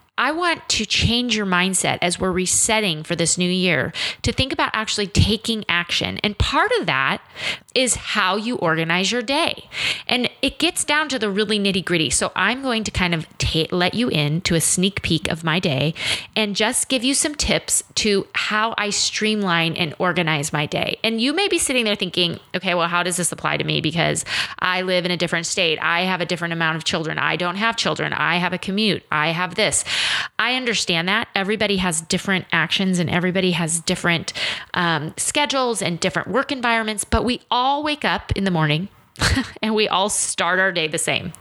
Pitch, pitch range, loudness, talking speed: 185 Hz, 170-220 Hz, -20 LUFS, 205 wpm